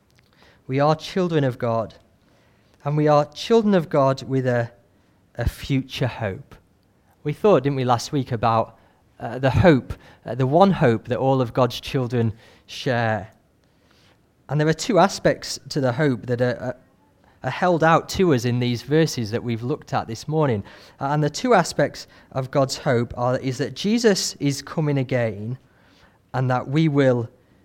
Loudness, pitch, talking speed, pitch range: -22 LUFS, 130 Hz, 175 wpm, 115-150 Hz